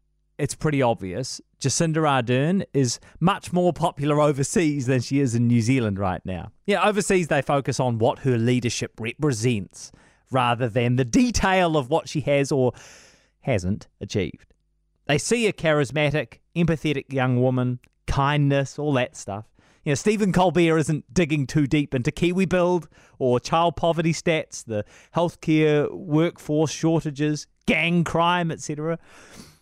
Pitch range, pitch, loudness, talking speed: 125-165 Hz, 145 Hz, -23 LUFS, 145 wpm